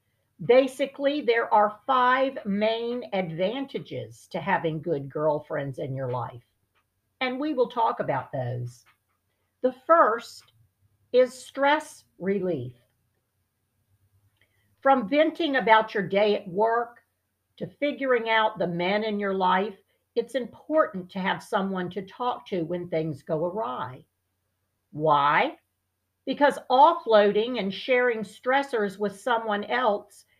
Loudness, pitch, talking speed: -25 LUFS, 205 Hz, 120 wpm